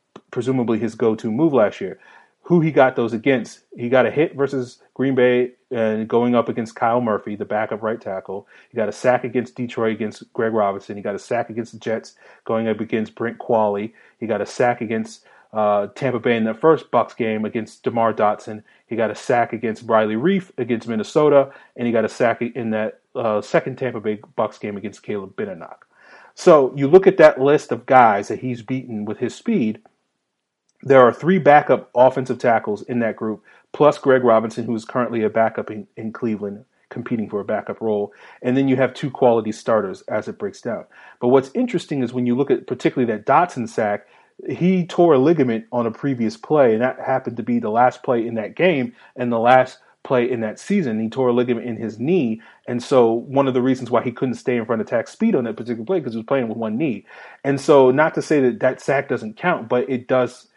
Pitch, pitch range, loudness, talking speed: 120 Hz, 115-135 Hz, -19 LUFS, 220 wpm